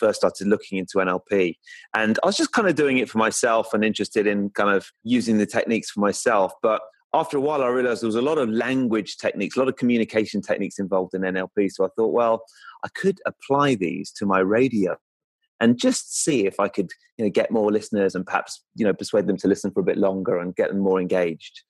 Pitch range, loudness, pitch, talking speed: 100-145 Hz, -22 LUFS, 115 Hz, 235 wpm